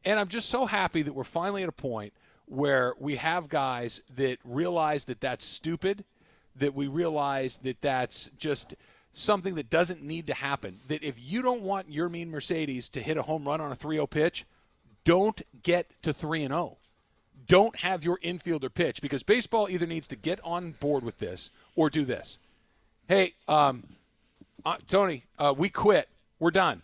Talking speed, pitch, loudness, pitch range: 185 wpm, 155 Hz, -29 LUFS, 135-175 Hz